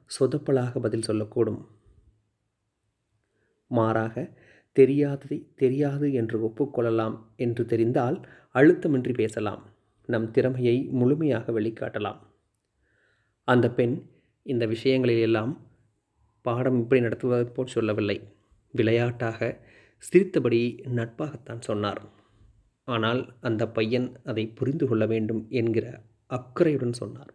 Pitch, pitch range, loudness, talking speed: 115 Hz, 110-130 Hz, -26 LUFS, 85 wpm